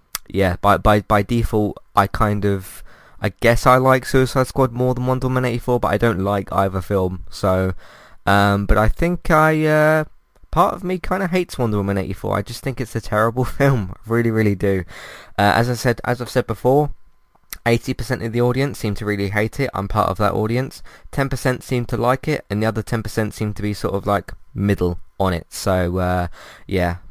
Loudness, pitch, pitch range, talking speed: -19 LUFS, 110 Hz, 100-125 Hz, 210 wpm